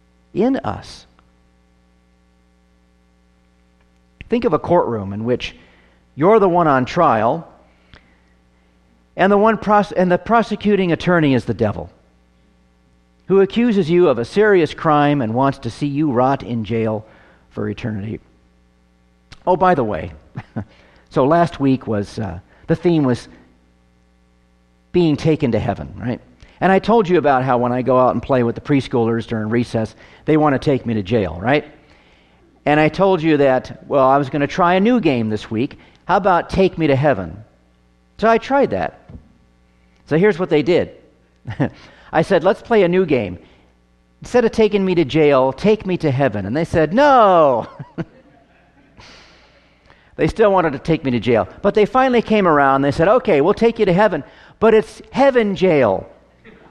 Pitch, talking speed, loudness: 125 Hz, 170 wpm, -16 LUFS